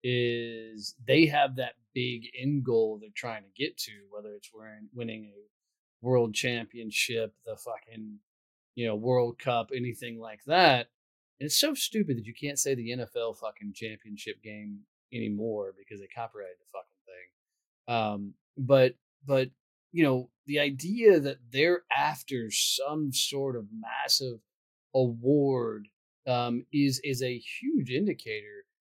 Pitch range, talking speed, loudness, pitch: 110-140 Hz, 150 wpm, -29 LUFS, 120 Hz